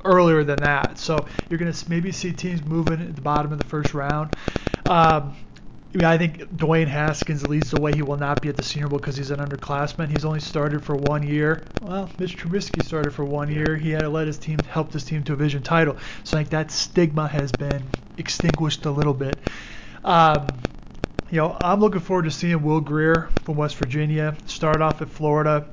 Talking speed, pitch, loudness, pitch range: 220 wpm, 155 Hz, -23 LUFS, 145-165 Hz